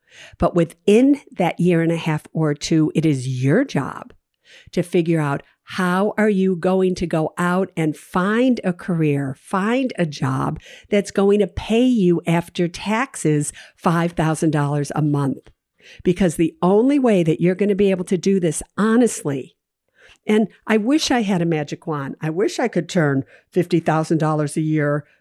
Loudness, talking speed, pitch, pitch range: -19 LUFS, 165 wpm, 175 Hz, 155-205 Hz